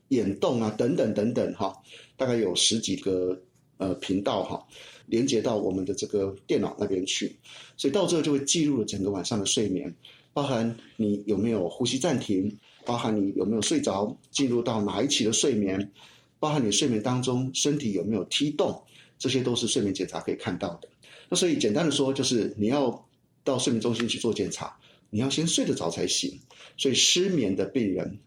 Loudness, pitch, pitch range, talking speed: -27 LUFS, 120 Hz, 100-140 Hz, 290 characters per minute